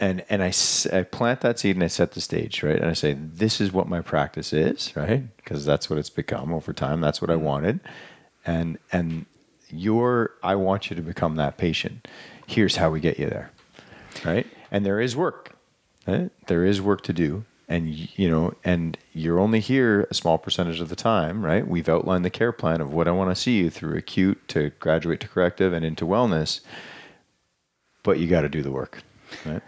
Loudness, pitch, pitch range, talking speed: -24 LUFS, 90 Hz, 80-100 Hz, 215 wpm